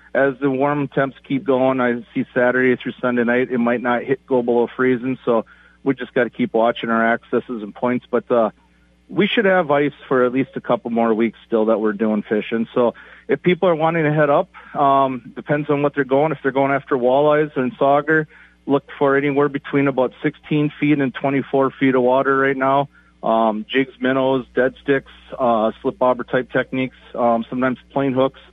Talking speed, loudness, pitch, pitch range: 205 wpm, -19 LUFS, 130 Hz, 120-140 Hz